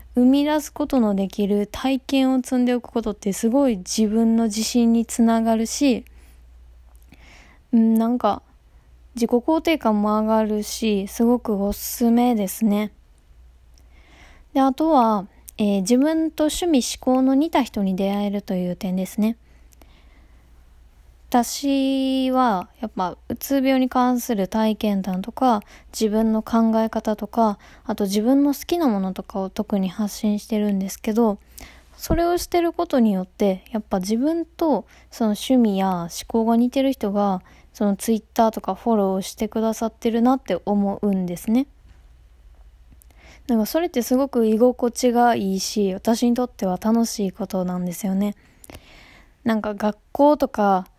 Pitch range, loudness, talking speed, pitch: 190-245 Hz, -21 LUFS, 285 characters per minute, 220 Hz